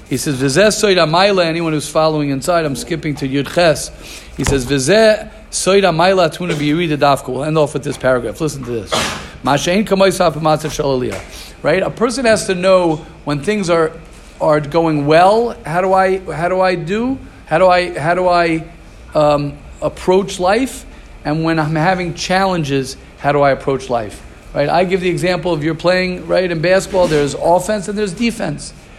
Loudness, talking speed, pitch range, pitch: -15 LUFS, 155 wpm, 150-190 Hz, 170 Hz